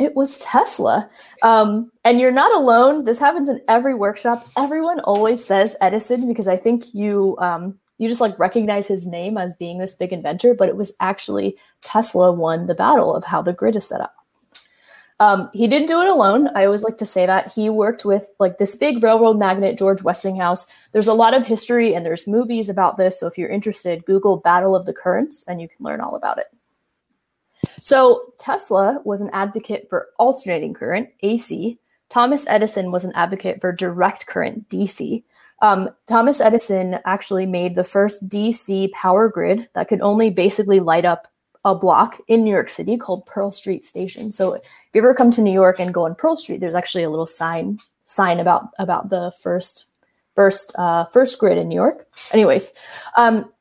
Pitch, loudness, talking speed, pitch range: 205 Hz, -17 LUFS, 195 wpm, 185-230 Hz